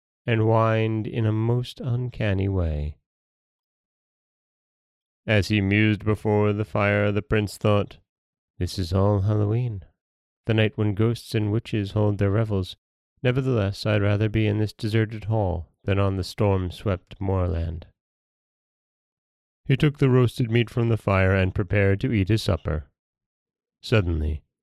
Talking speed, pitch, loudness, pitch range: 140 wpm, 105 Hz, -24 LUFS, 95-110 Hz